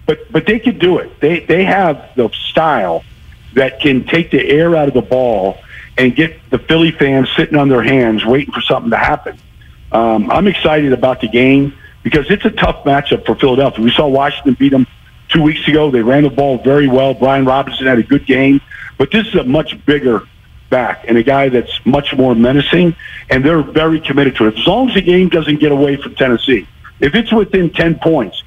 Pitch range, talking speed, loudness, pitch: 130-160 Hz, 215 wpm, -12 LUFS, 140 Hz